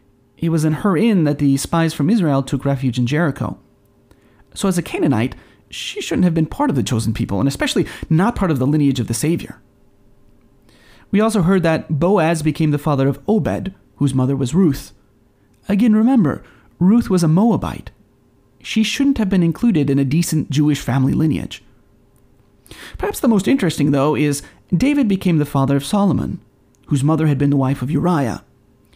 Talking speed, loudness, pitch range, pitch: 180 wpm, -17 LUFS, 135-185 Hz, 150 Hz